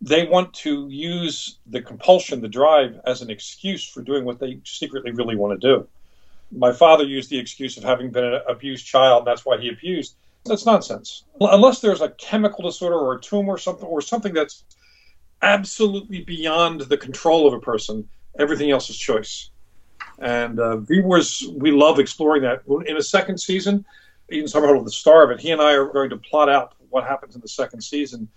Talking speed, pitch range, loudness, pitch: 195 wpm, 125-175 Hz, -19 LUFS, 145 Hz